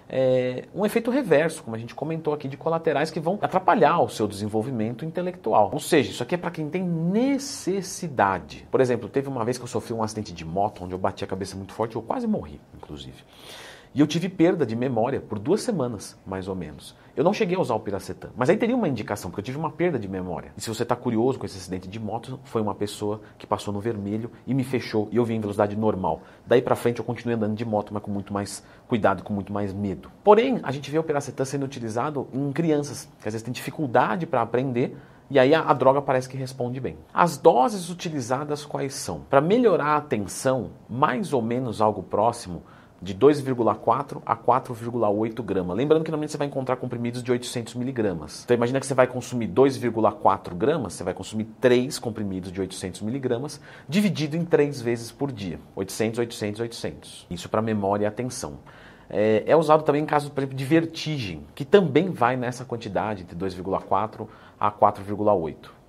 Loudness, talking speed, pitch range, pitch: -25 LUFS, 205 wpm, 105-145 Hz, 120 Hz